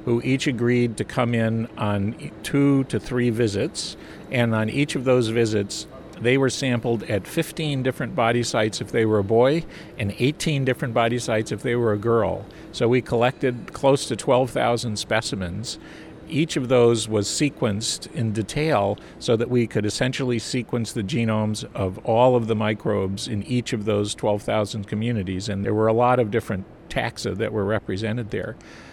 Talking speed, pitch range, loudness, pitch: 175 wpm, 110-130 Hz, -23 LUFS, 115 Hz